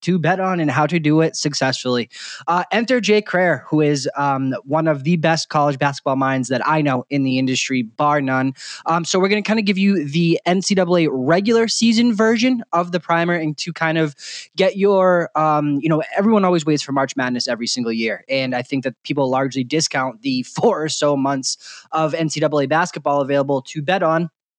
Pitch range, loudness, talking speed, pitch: 140-180 Hz, -18 LUFS, 205 wpm, 155 Hz